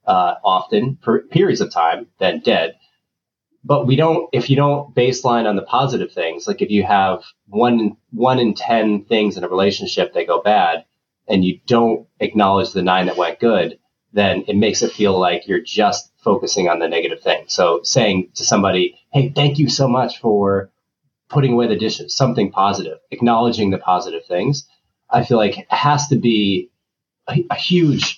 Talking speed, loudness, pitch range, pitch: 185 wpm, -17 LUFS, 100-135 Hz, 115 Hz